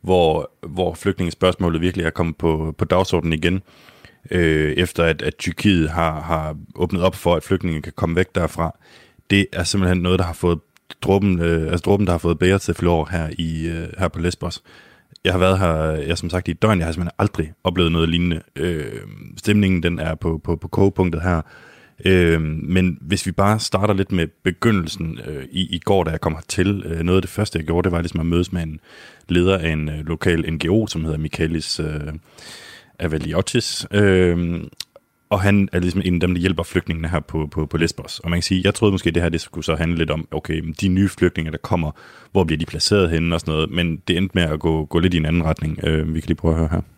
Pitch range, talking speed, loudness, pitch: 80-95 Hz, 230 wpm, -20 LUFS, 85 Hz